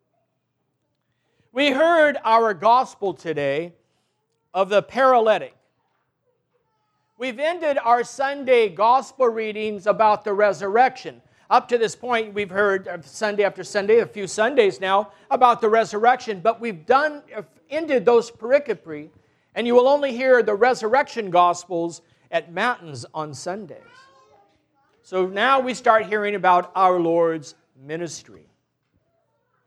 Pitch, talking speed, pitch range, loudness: 215 Hz, 120 wpm, 175-250 Hz, -20 LUFS